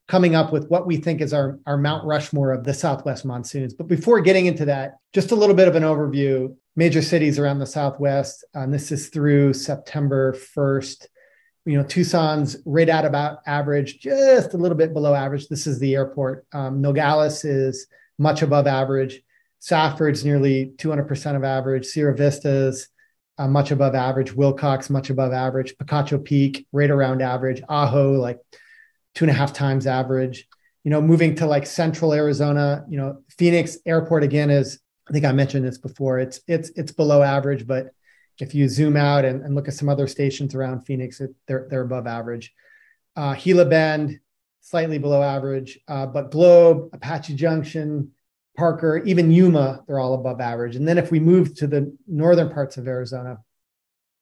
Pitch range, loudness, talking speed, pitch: 135-160 Hz, -20 LUFS, 180 wpm, 145 Hz